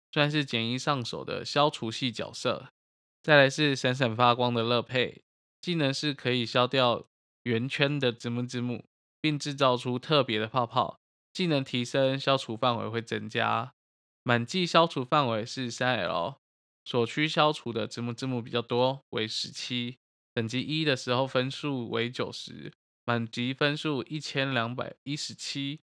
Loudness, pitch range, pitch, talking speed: -28 LUFS, 120-145 Hz, 125 Hz, 235 characters per minute